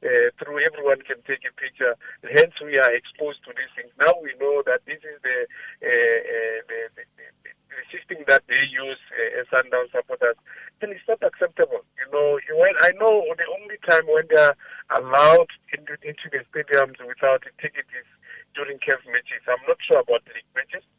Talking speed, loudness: 190 wpm, -21 LUFS